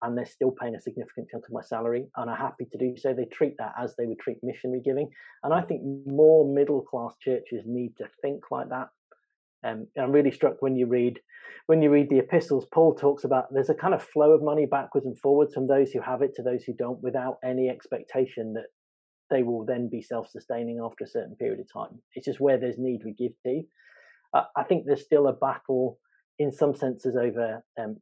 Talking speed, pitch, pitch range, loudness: 230 wpm, 130 Hz, 120-140 Hz, -26 LUFS